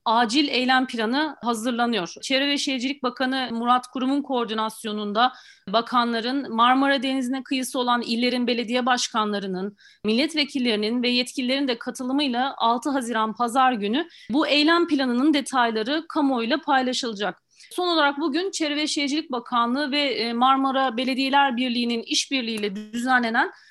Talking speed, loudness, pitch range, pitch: 120 wpm, -23 LUFS, 235-280 Hz, 255 Hz